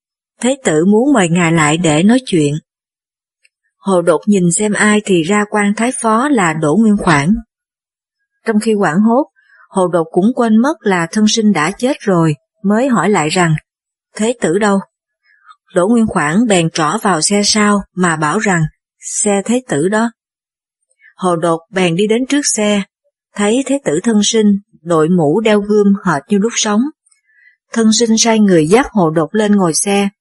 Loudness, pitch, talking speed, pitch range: -13 LUFS, 210 Hz, 180 wpm, 180-230 Hz